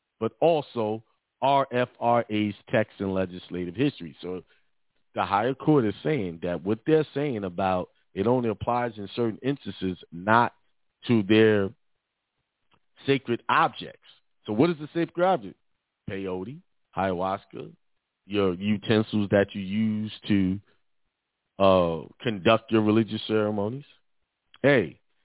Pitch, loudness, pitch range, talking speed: 110 Hz, -26 LUFS, 95-120 Hz, 115 wpm